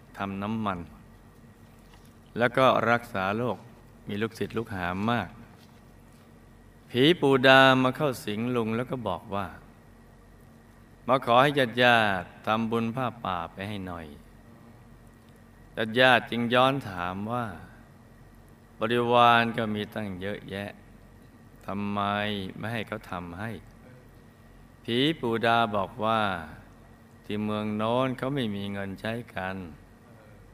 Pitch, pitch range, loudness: 115 Hz, 100-120 Hz, -26 LUFS